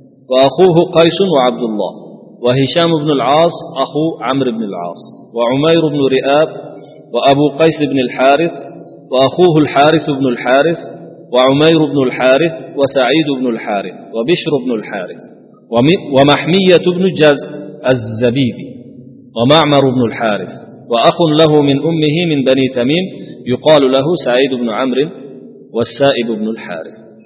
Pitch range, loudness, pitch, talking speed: 125-160 Hz, -12 LUFS, 140 Hz, 115 wpm